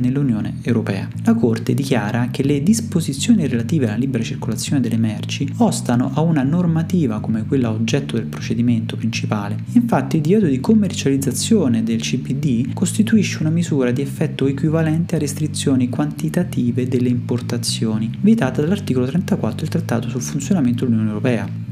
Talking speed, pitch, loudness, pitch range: 140 wpm, 130 Hz, -19 LUFS, 115-155 Hz